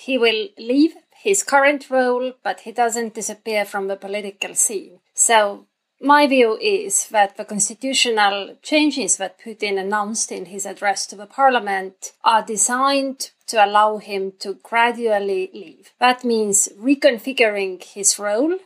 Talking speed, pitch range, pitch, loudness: 140 wpm, 200-260 Hz, 220 Hz, -19 LUFS